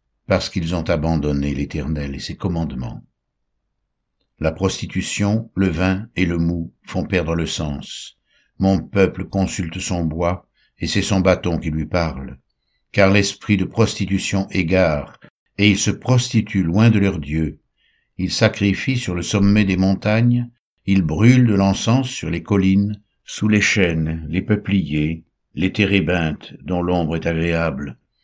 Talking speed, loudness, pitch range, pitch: 145 wpm, -19 LUFS, 80-100 Hz, 95 Hz